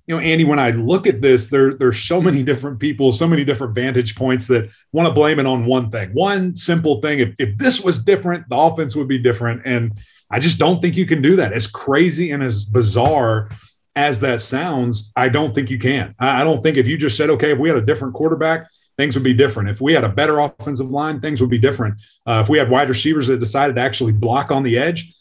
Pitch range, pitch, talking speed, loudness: 125-155 Hz, 135 Hz, 250 wpm, -17 LUFS